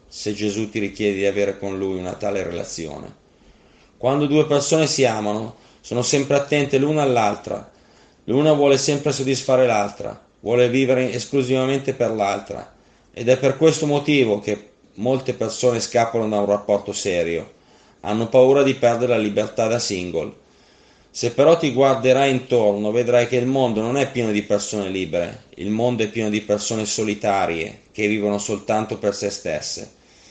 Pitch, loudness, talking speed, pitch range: 120 Hz, -20 LUFS, 160 wpm, 105-135 Hz